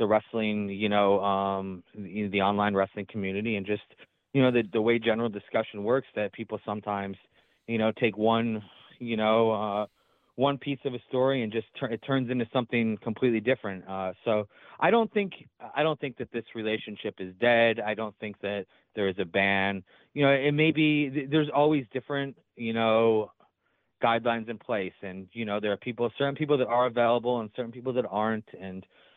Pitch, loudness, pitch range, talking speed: 115 Hz, -28 LUFS, 105-130 Hz, 195 wpm